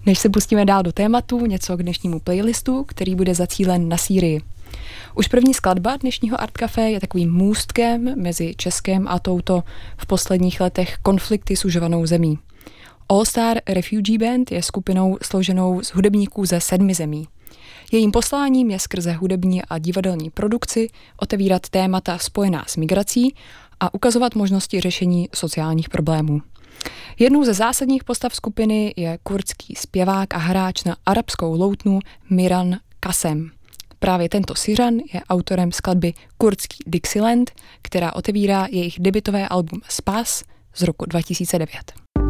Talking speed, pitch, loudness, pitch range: 140 wpm, 190 Hz, -20 LUFS, 175-215 Hz